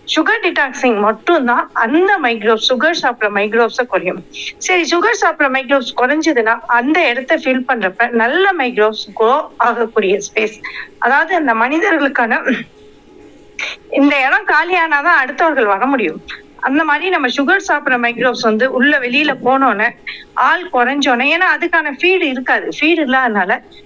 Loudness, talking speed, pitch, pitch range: -13 LUFS, 115 wpm, 265 Hz, 235-325 Hz